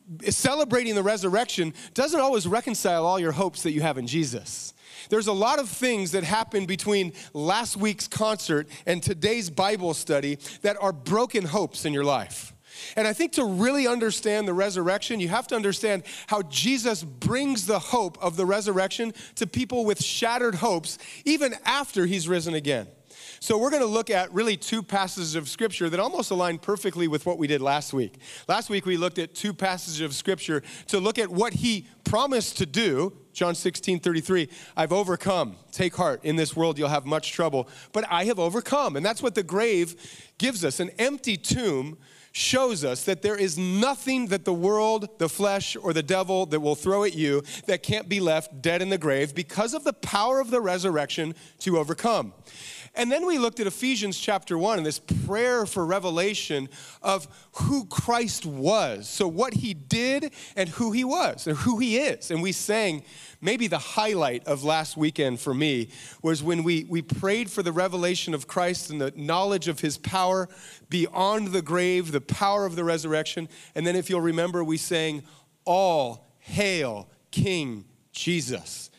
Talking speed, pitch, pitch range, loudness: 185 wpm, 185 Hz, 160-215 Hz, -26 LUFS